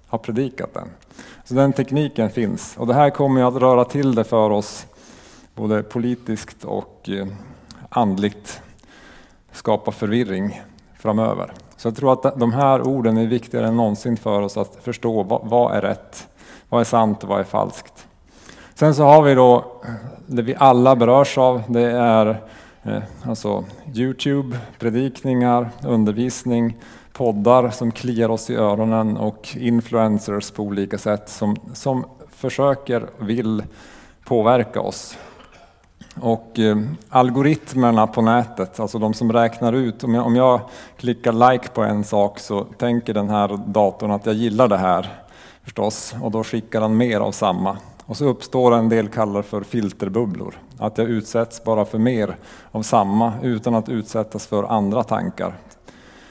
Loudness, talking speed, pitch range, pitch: -19 LUFS, 150 wpm, 105-125 Hz, 115 Hz